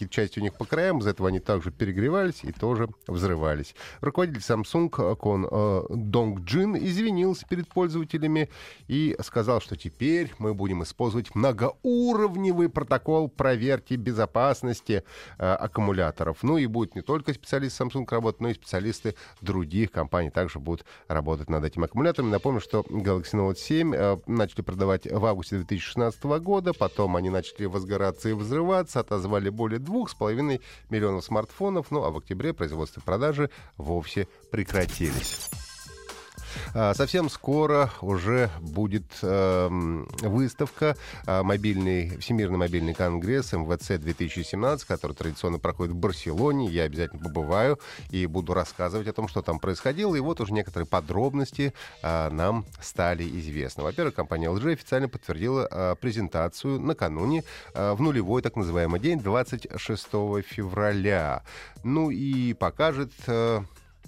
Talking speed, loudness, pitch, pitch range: 135 wpm, -27 LUFS, 105 Hz, 90-135 Hz